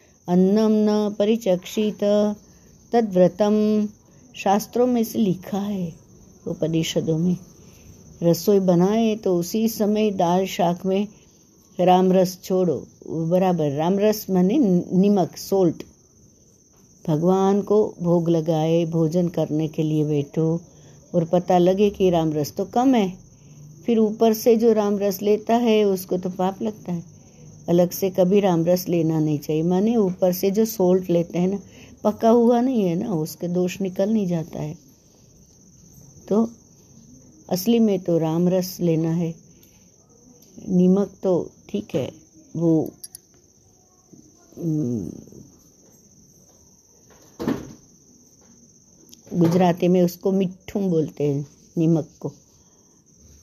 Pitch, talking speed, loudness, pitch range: 185 Hz, 120 wpm, -21 LUFS, 170-205 Hz